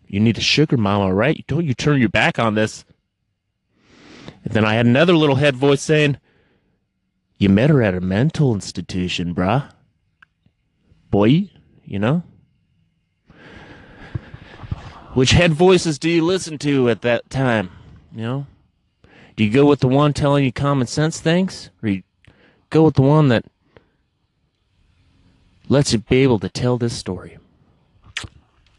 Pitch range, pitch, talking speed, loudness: 95-145 Hz, 120 Hz, 150 wpm, -17 LUFS